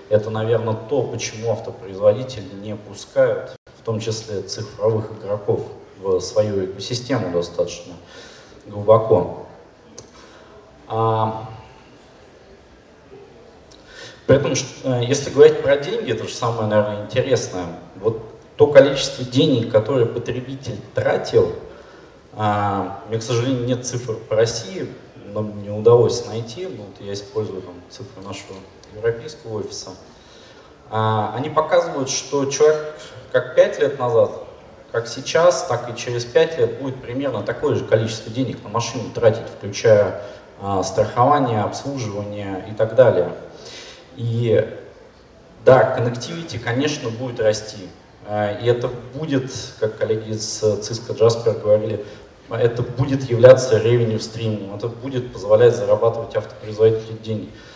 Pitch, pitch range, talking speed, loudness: 120 Hz, 110-145 Hz, 115 wpm, -20 LUFS